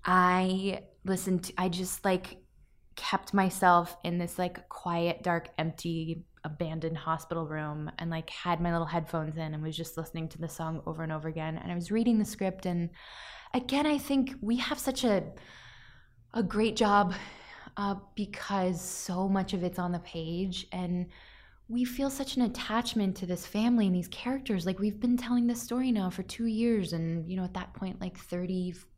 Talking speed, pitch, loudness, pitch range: 190 wpm, 185 Hz, -31 LUFS, 170-210 Hz